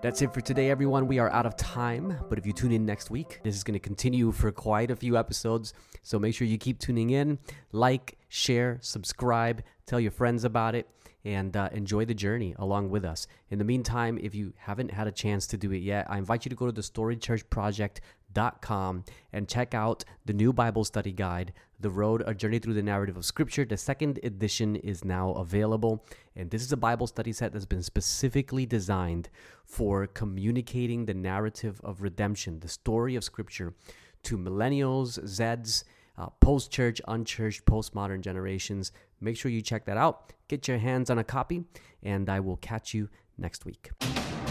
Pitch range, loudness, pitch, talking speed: 100-120 Hz, -30 LUFS, 110 Hz, 190 wpm